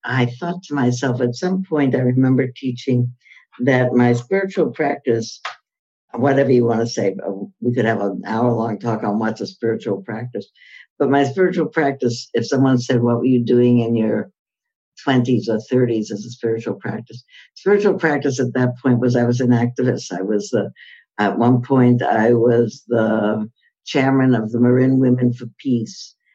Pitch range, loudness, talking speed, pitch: 115-130 Hz, -18 LUFS, 175 wpm, 125 Hz